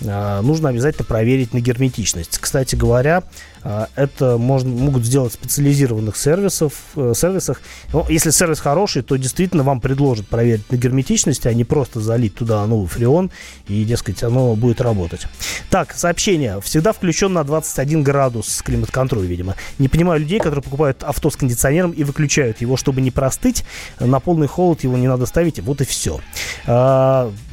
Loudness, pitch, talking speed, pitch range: -17 LUFS, 130 Hz, 160 wpm, 120-155 Hz